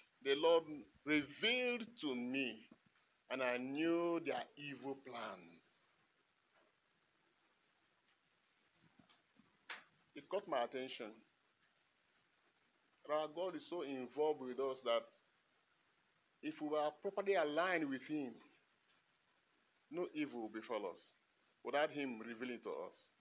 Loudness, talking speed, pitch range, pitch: -41 LUFS, 105 wpm, 130-170 Hz, 150 Hz